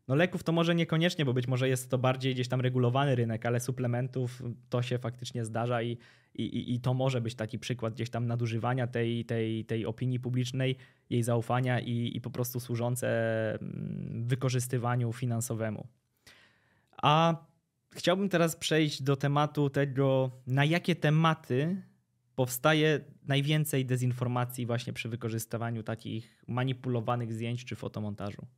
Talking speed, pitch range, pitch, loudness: 140 wpm, 120-135 Hz, 125 Hz, -31 LUFS